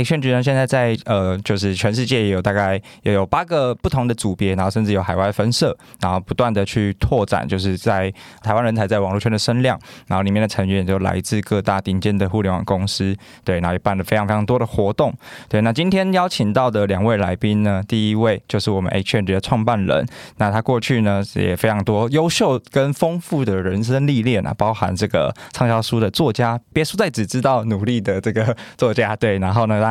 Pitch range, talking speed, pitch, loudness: 100-120 Hz, 335 characters per minute, 110 Hz, -19 LUFS